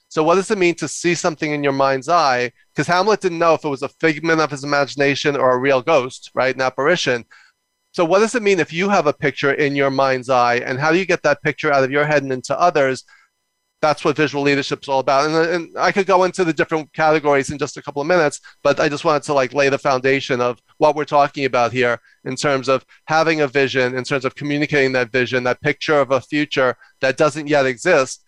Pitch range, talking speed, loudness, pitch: 135-155 Hz, 250 wpm, -18 LUFS, 145 Hz